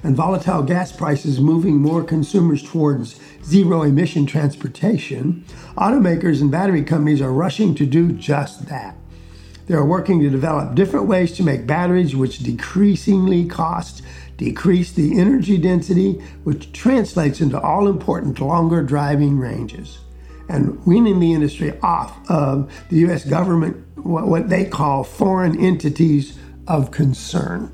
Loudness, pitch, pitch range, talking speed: -18 LUFS, 160 Hz, 145-180 Hz, 135 wpm